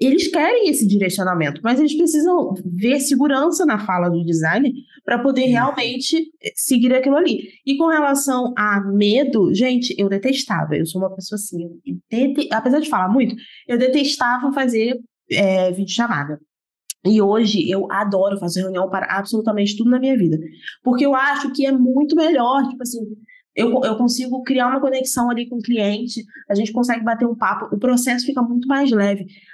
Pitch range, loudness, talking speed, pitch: 200-270 Hz, -18 LUFS, 175 wpm, 245 Hz